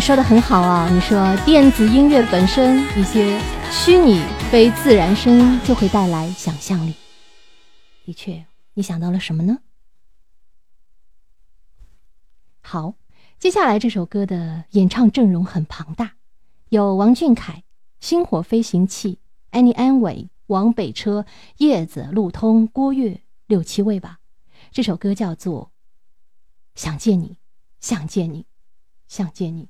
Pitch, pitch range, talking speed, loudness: 200 Hz, 170-230 Hz, 190 characters per minute, -17 LUFS